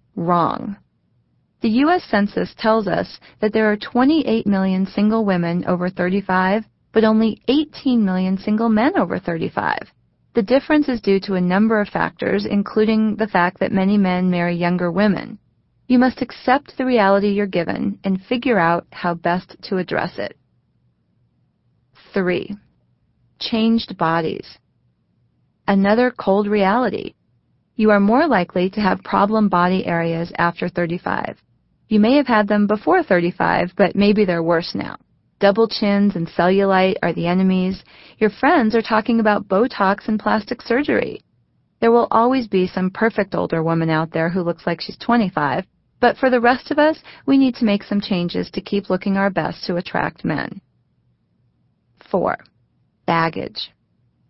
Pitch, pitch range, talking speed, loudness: 205 Hz, 180-225 Hz, 150 wpm, -18 LUFS